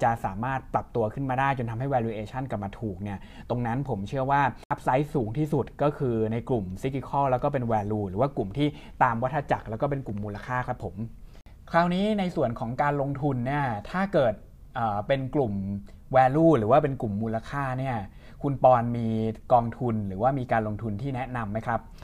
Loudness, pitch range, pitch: -27 LUFS, 110-140 Hz, 125 Hz